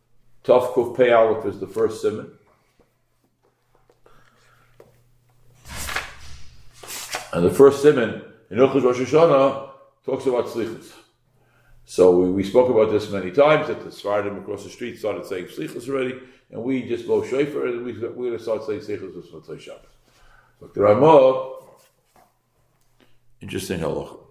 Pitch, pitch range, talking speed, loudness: 130 Hz, 115-160 Hz, 135 wpm, -20 LUFS